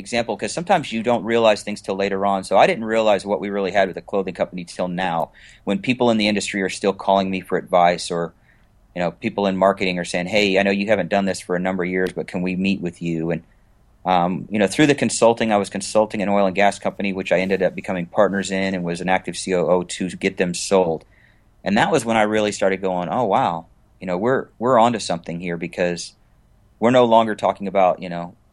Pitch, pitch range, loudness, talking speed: 95 Hz, 90-105 Hz, -20 LUFS, 245 wpm